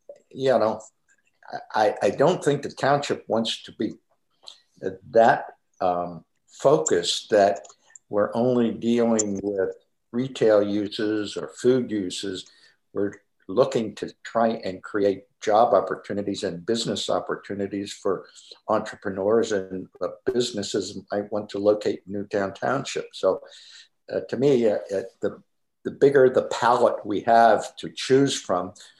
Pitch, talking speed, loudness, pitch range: 110 Hz, 125 wpm, -24 LUFS, 100-135 Hz